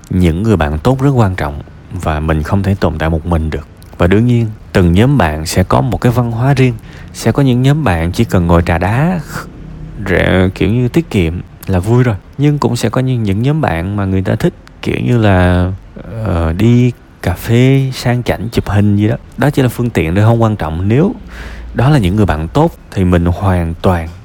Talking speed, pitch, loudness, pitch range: 230 wpm, 100 Hz, -13 LUFS, 85-120 Hz